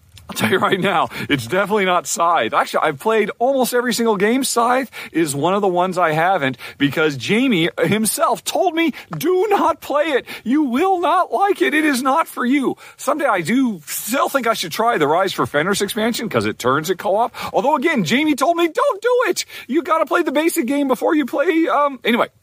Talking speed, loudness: 215 wpm, -18 LUFS